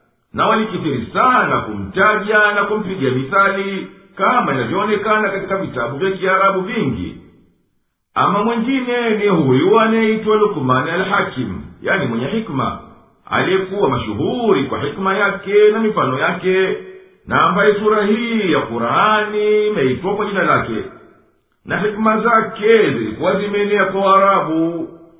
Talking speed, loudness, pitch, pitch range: 115 wpm, -16 LUFS, 200 Hz, 180-215 Hz